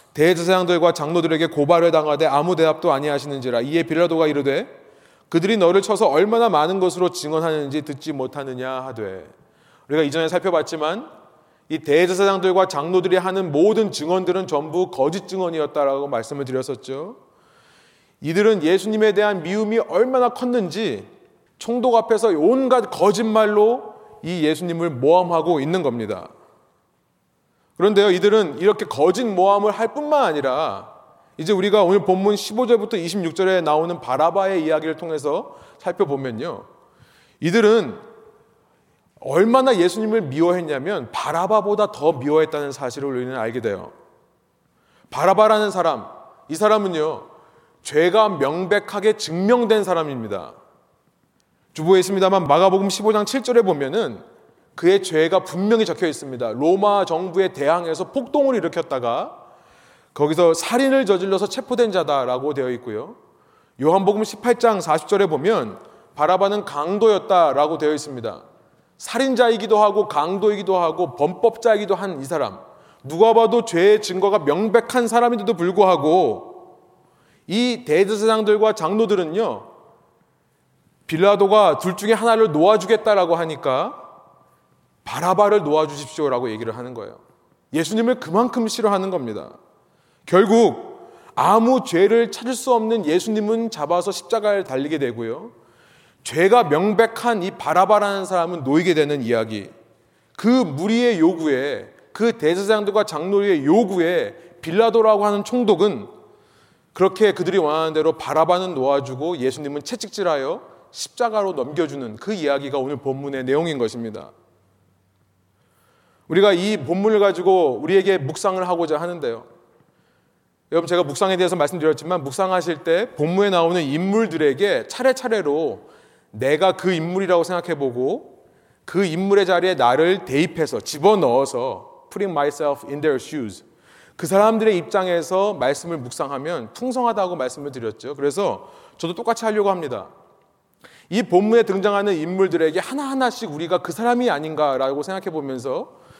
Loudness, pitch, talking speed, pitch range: -19 LUFS, 190 Hz, 330 characters per minute, 155-220 Hz